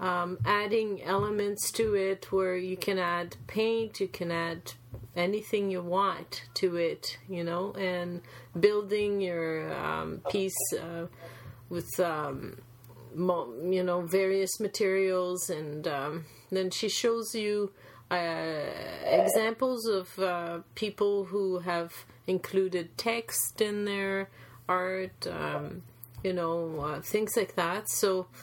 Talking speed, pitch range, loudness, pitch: 120 wpm, 165-200 Hz, -31 LUFS, 185 Hz